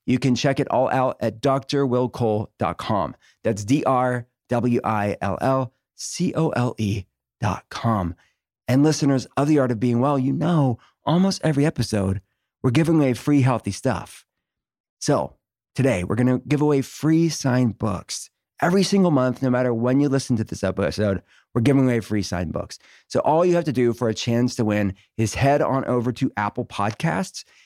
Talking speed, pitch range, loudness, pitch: 165 wpm, 110-140 Hz, -22 LUFS, 125 Hz